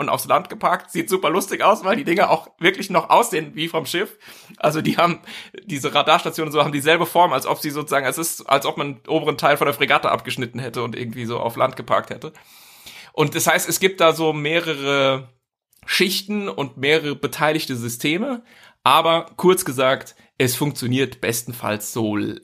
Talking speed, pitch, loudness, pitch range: 195 wpm, 150 Hz, -20 LUFS, 130-165 Hz